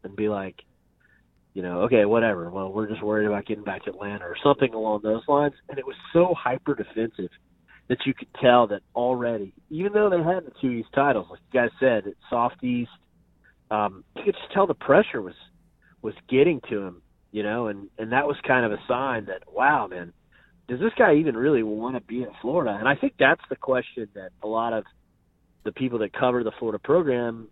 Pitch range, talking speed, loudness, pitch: 105-135 Hz, 220 wpm, -24 LUFS, 120 Hz